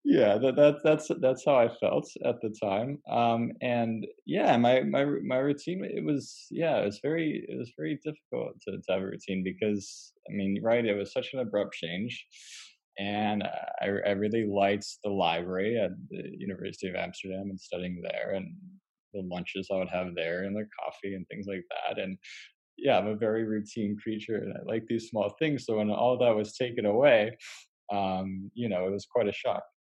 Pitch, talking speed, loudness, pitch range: 105 Hz, 200 wpm, -30 LUFS, 100-125 Hz